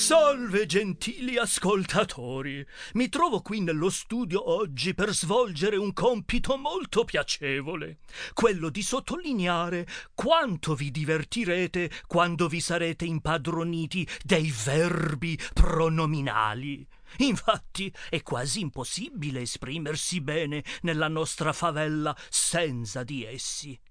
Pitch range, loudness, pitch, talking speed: 155-205 Hz, -28 LUFS, 170 Hz, 100 wpm